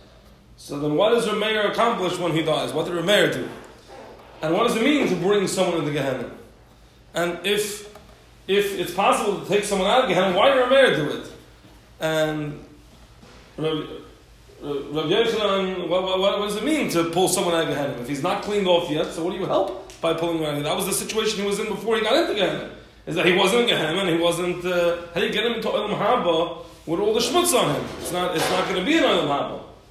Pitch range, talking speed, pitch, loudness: 165-210 Hz, 230 wpm, 185 Hz, -22 LUFS